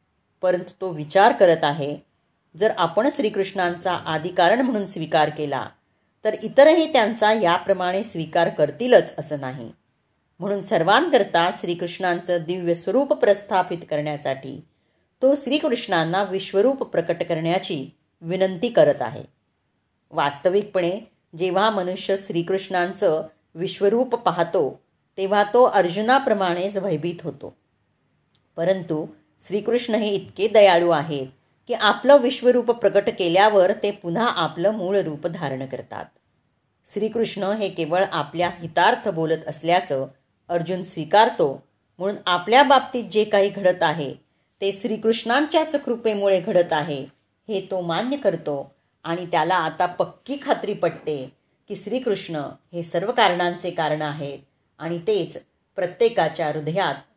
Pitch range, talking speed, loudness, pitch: 160-210 Hz, 110 wpm, -21 LUFS, 185 Hz